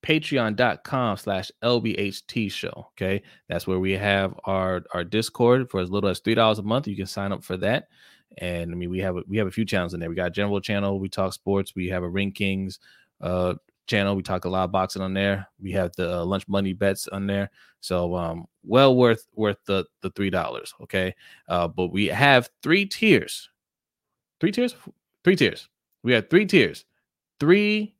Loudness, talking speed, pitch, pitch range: -24 LUFS, 205 wpm, 100 Hz, 95-110 Hz